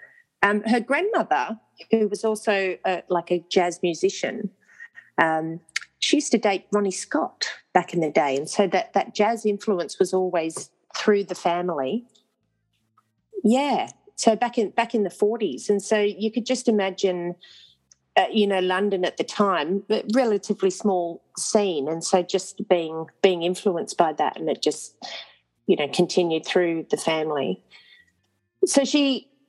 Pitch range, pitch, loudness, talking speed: 180-225 Hz, 200 Hz, -23 LUFS, 155 wpm